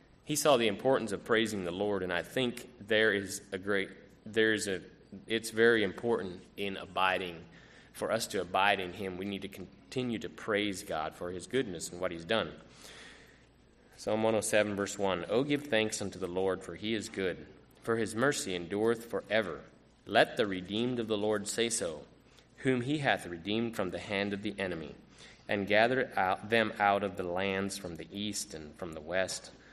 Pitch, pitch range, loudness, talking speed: 100 Hz, 95-110 Hz, -32 LUFS, 190 wpm